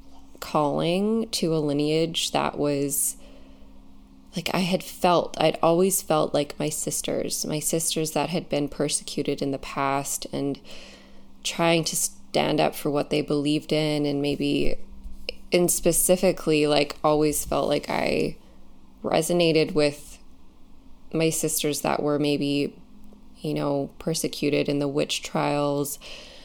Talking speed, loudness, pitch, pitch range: 130 wpm, -24 LUFS, 150 Hz, 135-165 Hz